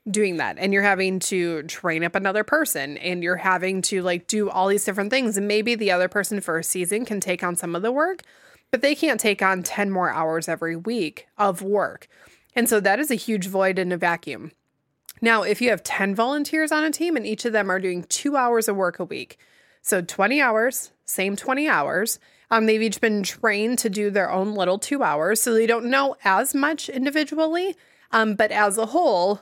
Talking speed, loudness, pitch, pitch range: 220 wpm, -22 LUFS, 205 Hz, 185-235 Hz